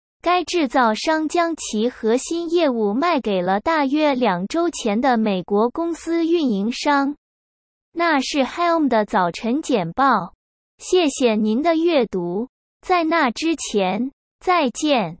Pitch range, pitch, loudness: 220-330 Hz, 275 Hz, -20 LUFS